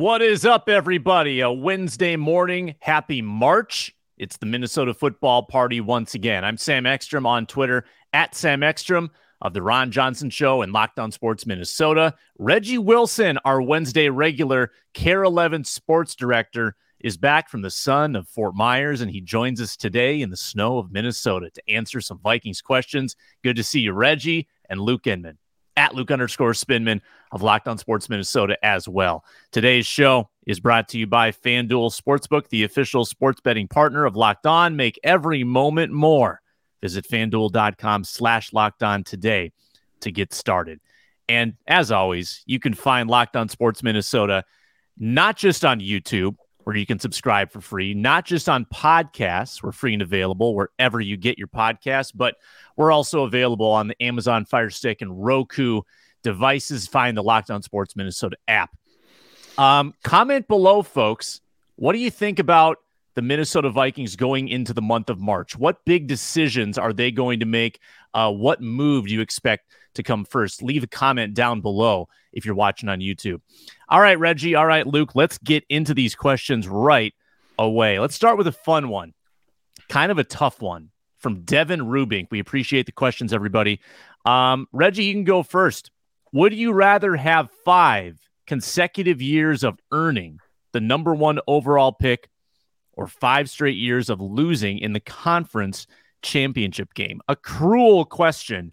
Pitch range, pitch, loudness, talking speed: 110-150 Hz, 125 Hz, -20 LUFS, 170 wpm